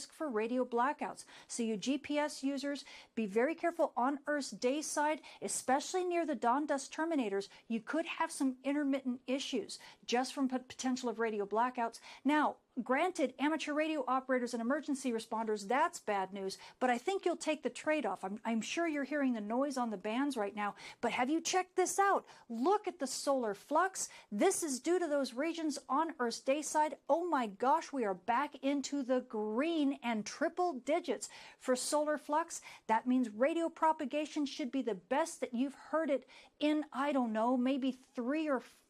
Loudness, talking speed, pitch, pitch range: -35 LUFS, 185 wpm, 275 Hz, 245-305 Hz